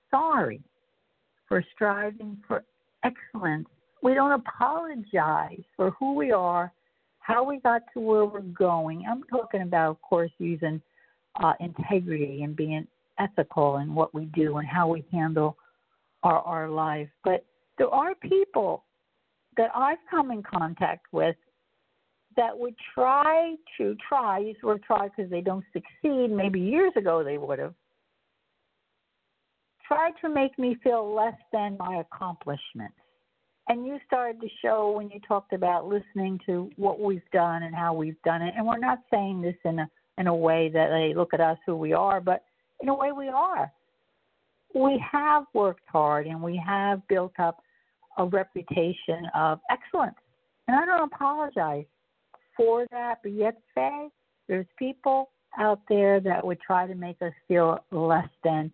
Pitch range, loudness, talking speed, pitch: 170-250 Hz, -27 LUFS, 160 wpm, 200 Hz